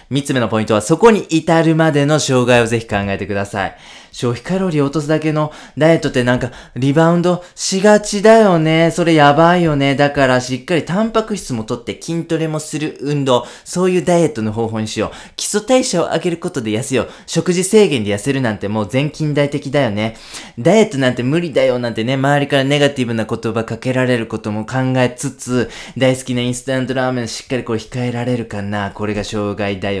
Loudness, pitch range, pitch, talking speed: -16 LUFS, 115-165 Hz, 135 Hz, 435 characters per minute